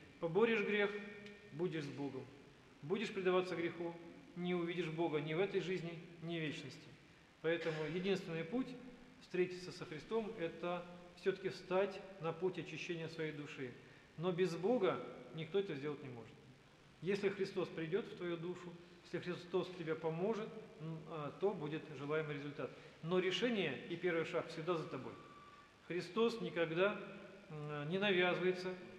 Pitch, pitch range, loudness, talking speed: 175 Hz, 155-190 Hz, -41 LUFS, 135 wpm